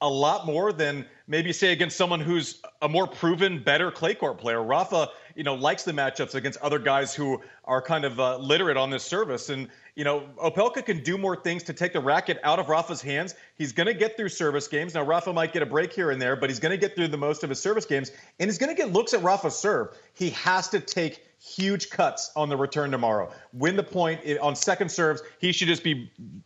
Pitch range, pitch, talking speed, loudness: 145-185 Hz, 160 Hz, 245 wpm, -26 LUFS